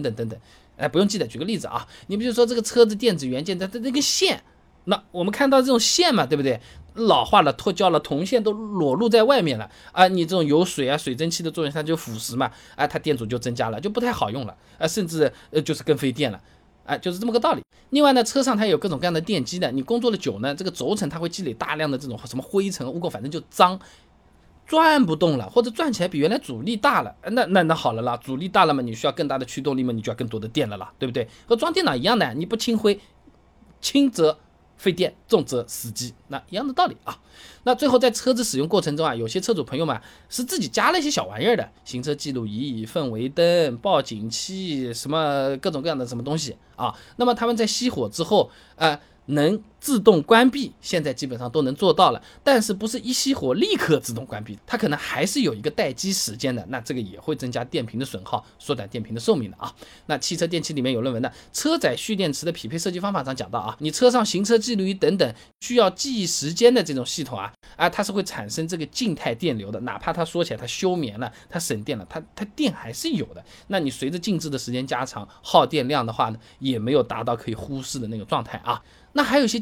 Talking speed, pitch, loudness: 360 characters per minute, 165 Hz, -23 LUFS